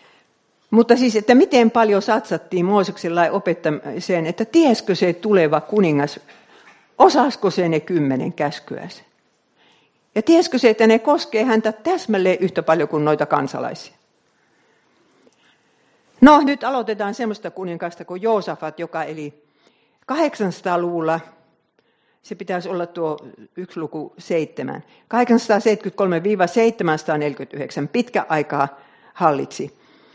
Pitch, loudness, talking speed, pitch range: 185 Hz, -19 LUFS, 105 wpm, 160-225 Hz